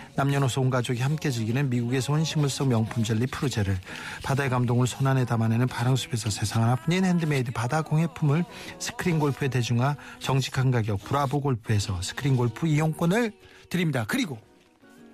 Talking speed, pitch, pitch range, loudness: 400 characters per minute, 130 Hz, 120-145 Hz, -26 LUFS